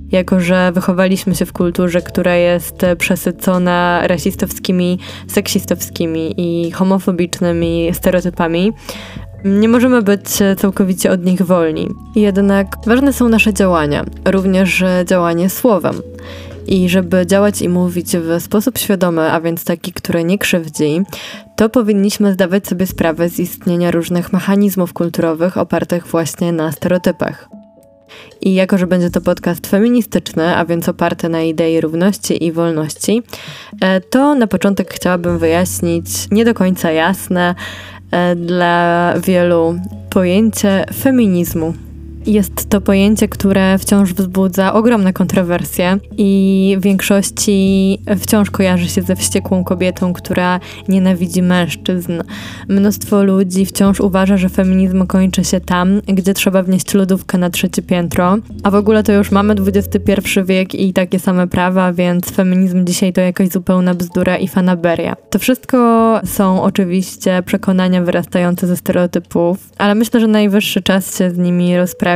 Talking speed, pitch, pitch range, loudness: 130 wpm, 185 Hz, 175-200 Hz, -14 LUFS